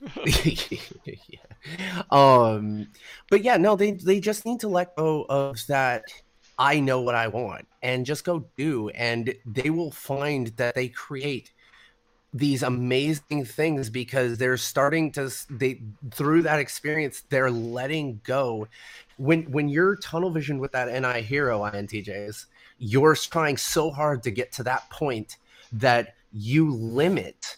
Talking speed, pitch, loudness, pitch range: 145 wpm, 135 Hz, -25 LUFS, 120-155 Hz